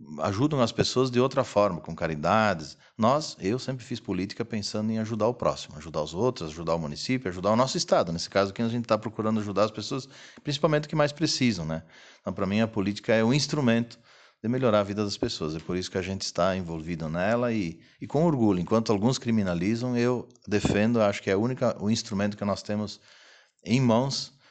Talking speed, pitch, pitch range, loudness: 215 wpm, 110 Hz, 95-125 Hz, -27 LUFS